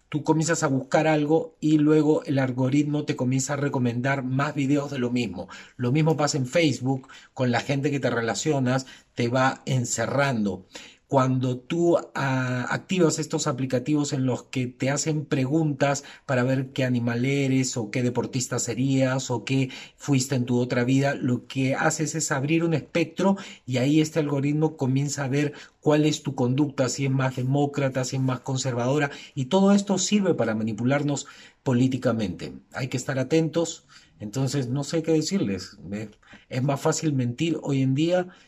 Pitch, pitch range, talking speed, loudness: 135 Hz, 130-150 Hz, 170 wpm, -25 LUFS